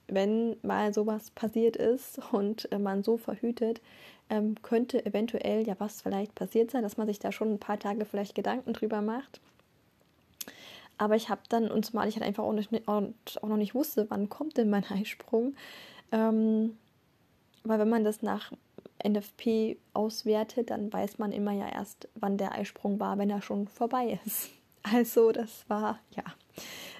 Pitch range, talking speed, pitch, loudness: 210-230 Hz, 165 wpm, 215 Hz, -31 LUFS